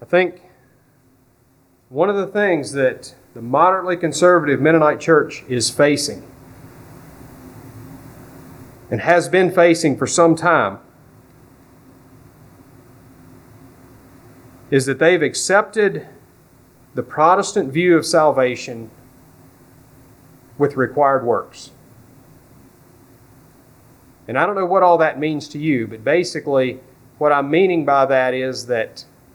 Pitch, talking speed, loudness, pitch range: 140 Hz, 105 wpm, -17 LUFS, 130-170 Hz